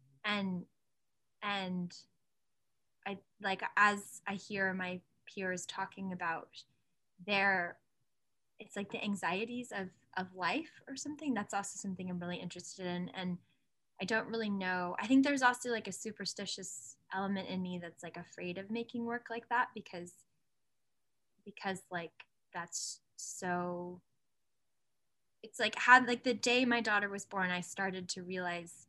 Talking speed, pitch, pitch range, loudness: 145 wpm, 195 Hz, 180-215 Hz, -36 LUFS